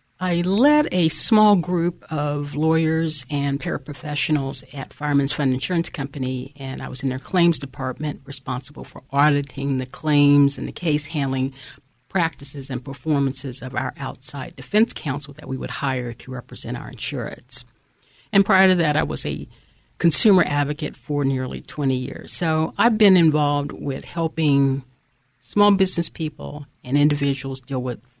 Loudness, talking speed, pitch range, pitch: -22 LUFS, 155 wpm, 135-160 Hz, 145 Hz